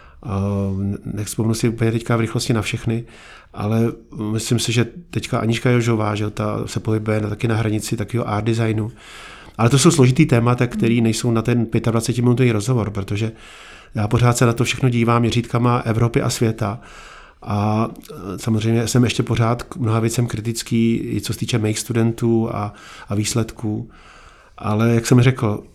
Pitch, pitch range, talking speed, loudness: 115 Hz, 110-120 Hz, 170 wpm, -19 LUFS